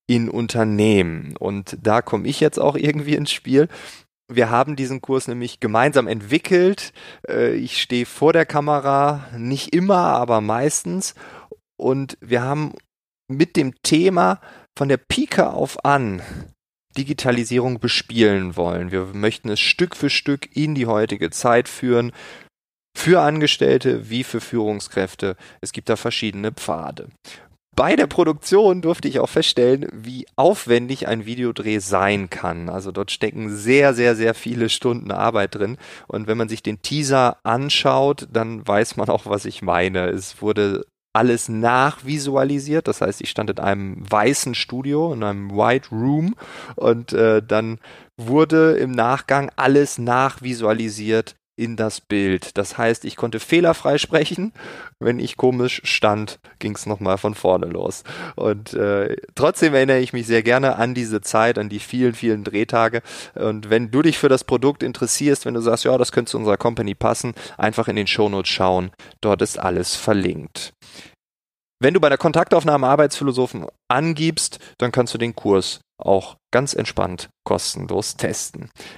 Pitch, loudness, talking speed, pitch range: 120 Hz, -19 LUFS, 155 wpm, 105-140 Hz